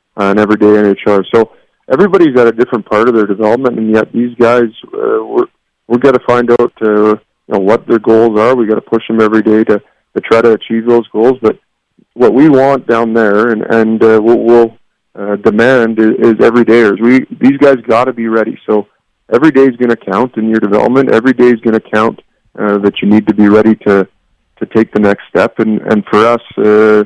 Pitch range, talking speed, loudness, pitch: 105-120 Hz, 220 wpm, -9 LUFS, 115 Hz